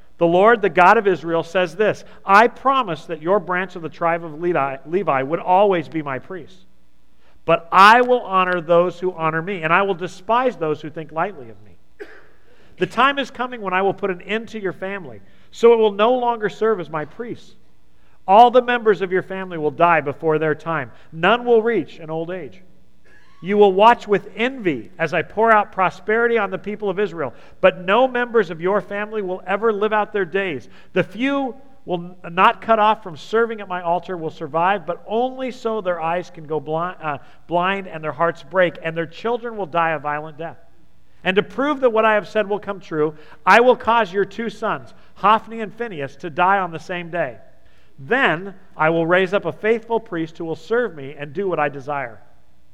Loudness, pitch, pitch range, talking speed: -19 LUFS, 185 Hz, 165-215 Hz, 210 wpm